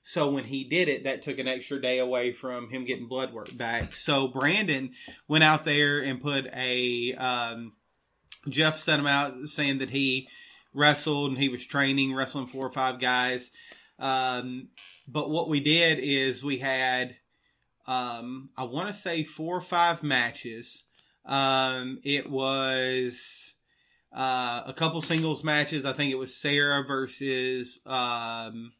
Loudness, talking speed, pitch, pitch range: -27 LUFS, 155 wpm, 135 Hz, 130-145 Hz